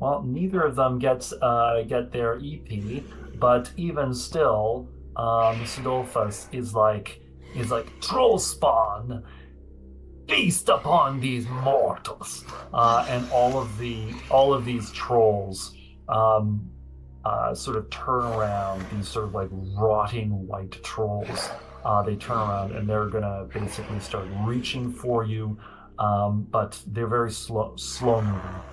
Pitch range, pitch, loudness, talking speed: 100-125 Hz, 110 Hz, -25 LUFS, 135 wpm